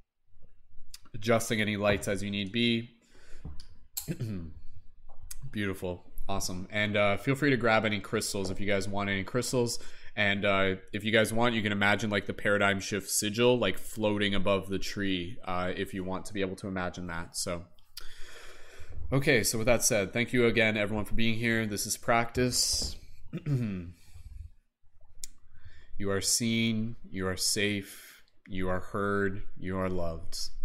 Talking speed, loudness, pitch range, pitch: 155 wpm, -30 LUFS, 95-110 Hz, 100 Hz